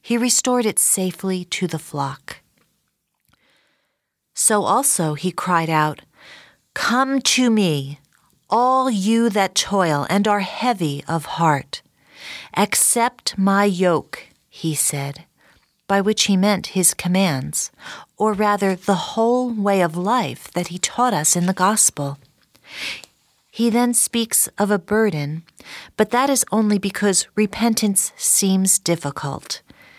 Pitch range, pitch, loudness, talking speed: 170-225 Hz, 195 Hz, -19 LUFS, 125 wpm